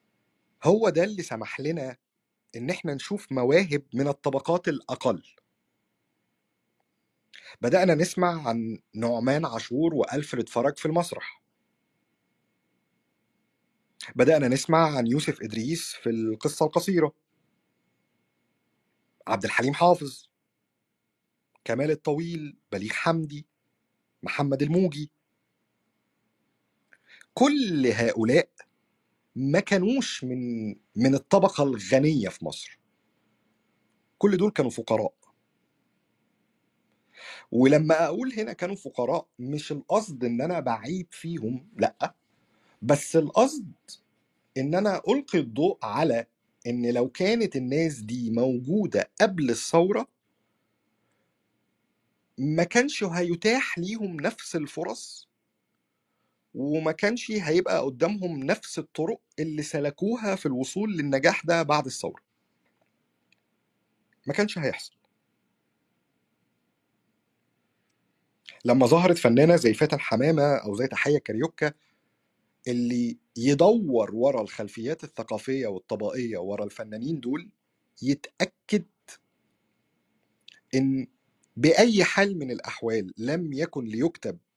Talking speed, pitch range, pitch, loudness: 90 wpm, 125-175 Hz, 150 Hz, -26 LUFS